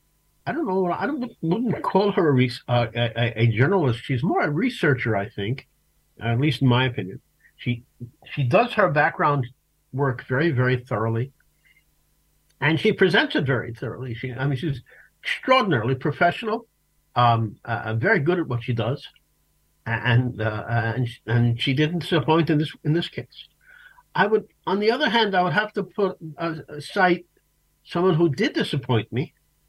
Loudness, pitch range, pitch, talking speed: -23 LUFS, 120-180 Hz, 140 Hz, 170 wpm